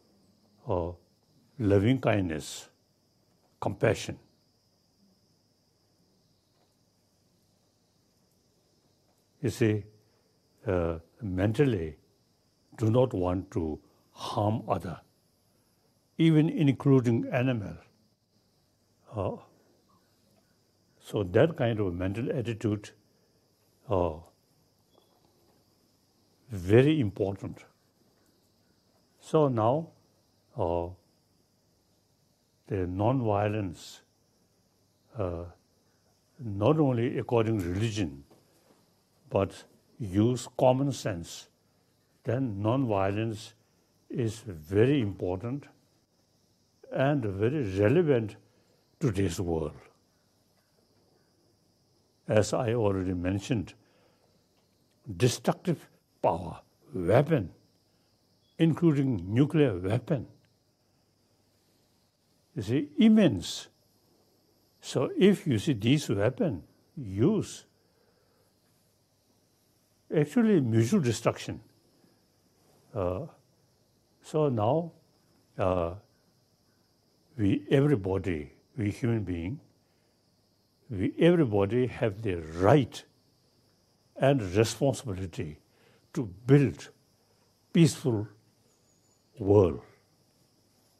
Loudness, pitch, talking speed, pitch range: -28 LUFS, 110 Hz, 65 wpm, 95-130 Hz